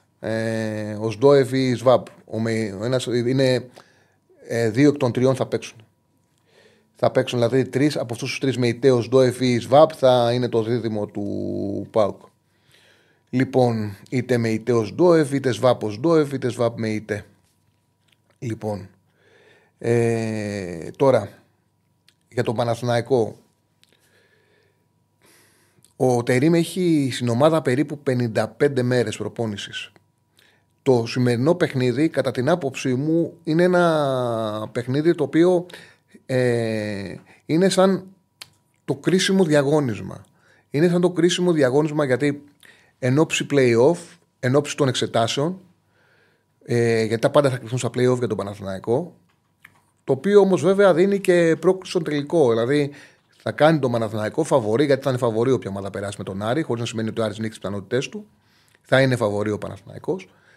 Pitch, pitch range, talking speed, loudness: 125 Hz, 115-145 Hz, 145 wpm, -21 LUFS